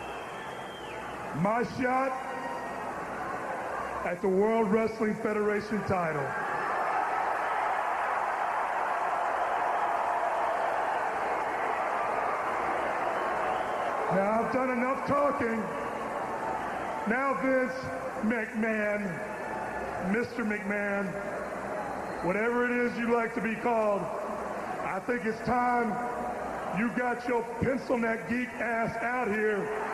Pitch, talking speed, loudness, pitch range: 225 Hz, 80 wpm, -30 LUFS, 210-245 Hz